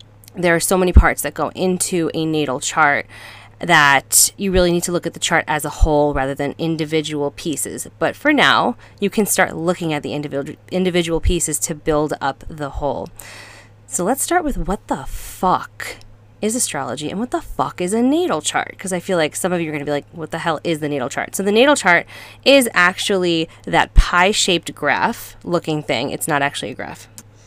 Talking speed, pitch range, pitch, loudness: 210 wpm, 145-185 Hz, 165 Hz, -18 LUFS